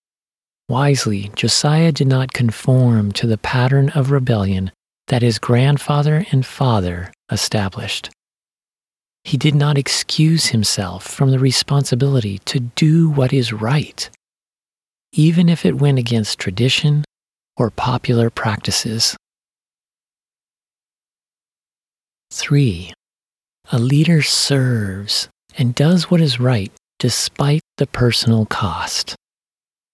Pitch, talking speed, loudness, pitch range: 125 Hz, 100 wpm, -16 LUFS, 110-145 Hz